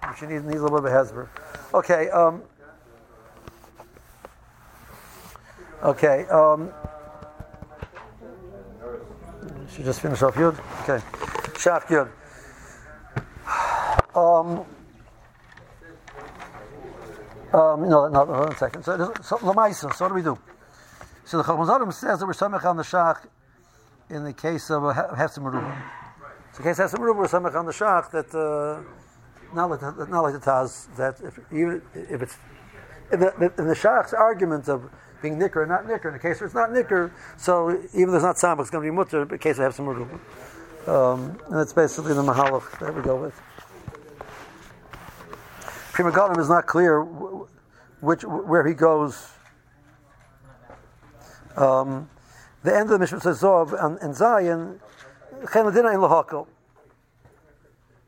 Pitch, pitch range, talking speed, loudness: 155 Hz, 135-175 Hz, 145 wpm, -22 LUFS